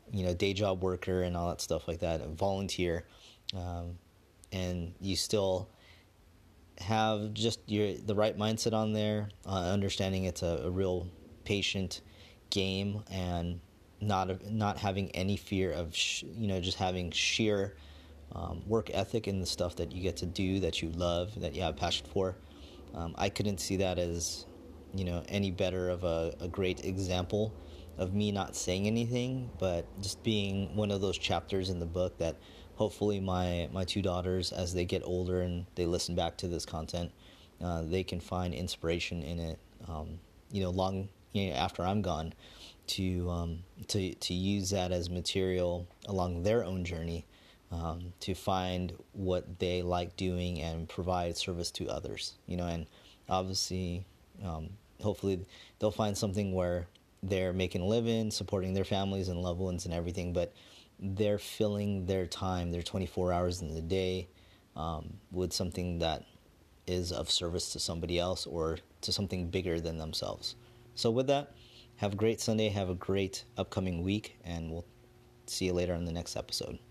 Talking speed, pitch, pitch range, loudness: 175 wpm, 90 Hz, 85-100 Hz, -34 LUFS